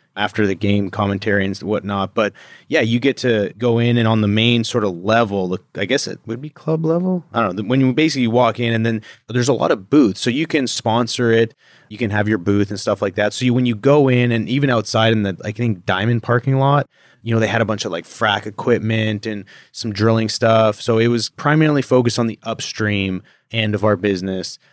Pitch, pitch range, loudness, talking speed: 115 Hz, 105-125 Hz, -18 LUFS, 240 wpm